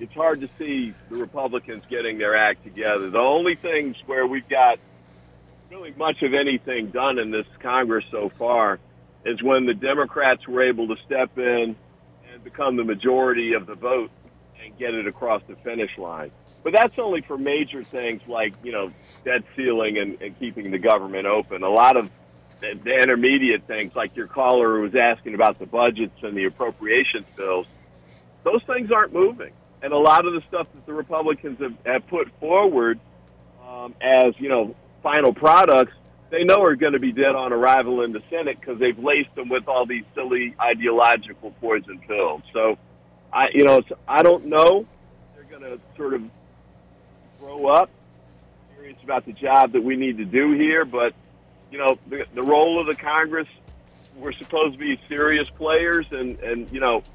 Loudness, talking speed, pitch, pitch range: -21 LUFS, 185 wpm, 125 Hz, 100-140 Hz